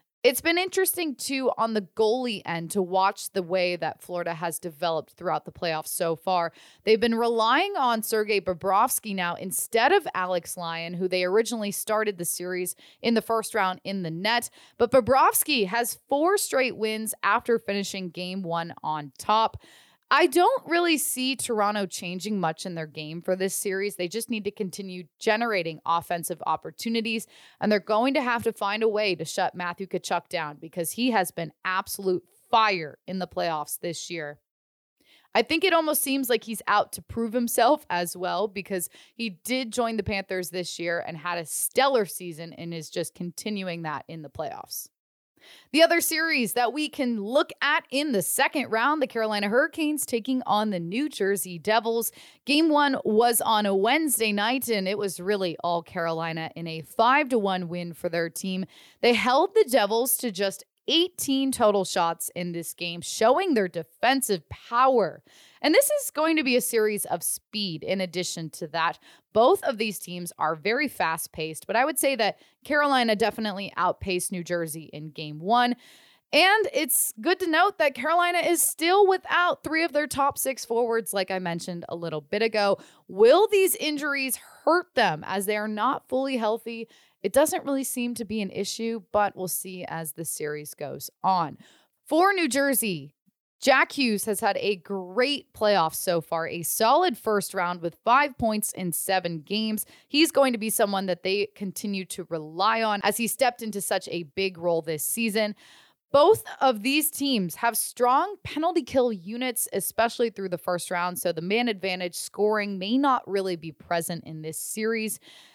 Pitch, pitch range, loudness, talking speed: 210 Hz, 175-255 Hz, -25 LUFS, 180 wpm